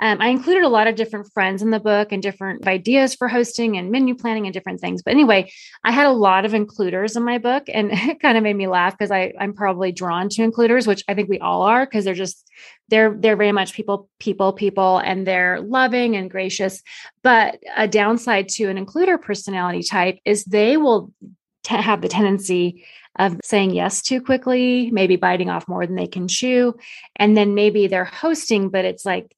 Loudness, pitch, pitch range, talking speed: -18 LUFS, 205 Hz, 190-230 Hz, 210 wpm